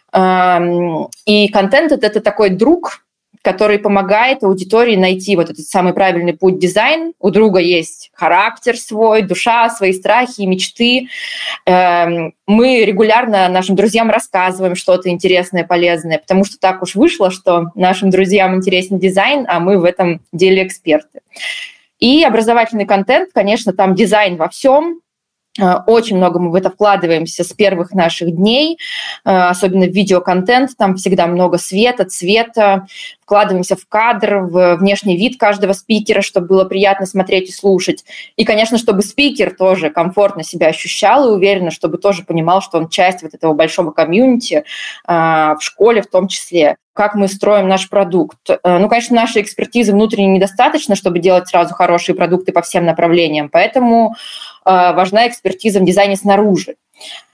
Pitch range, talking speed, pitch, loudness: 180-220 Hz, 145 wpm, 195 Hz, -12 LUFS